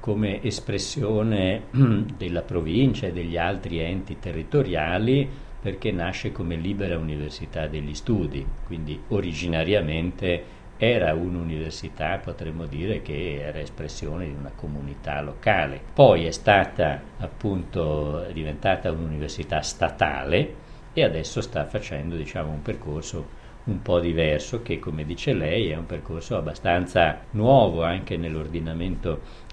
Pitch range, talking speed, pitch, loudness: 75-100 Hz, 115 wpm, 85 Hz, -25 LUFS